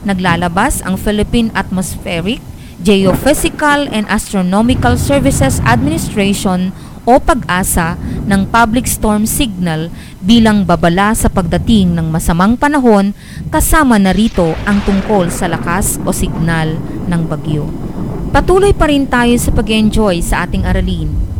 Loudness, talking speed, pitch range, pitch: -12 LUFS, 120 wpm, 170-225 Hz, 195 Hz